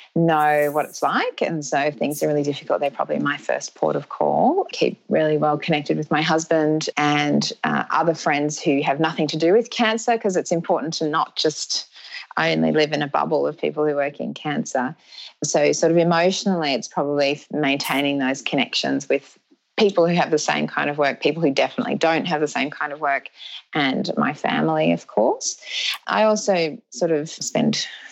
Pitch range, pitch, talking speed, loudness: 145-165 Hz, 155 Hz, 195 wpm, -21 LUFS